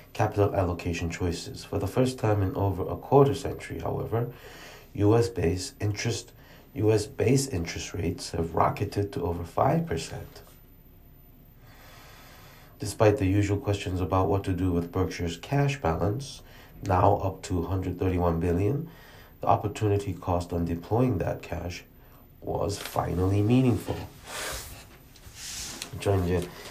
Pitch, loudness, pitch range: 100 Hz, -28 LUFS, 90-115 Hz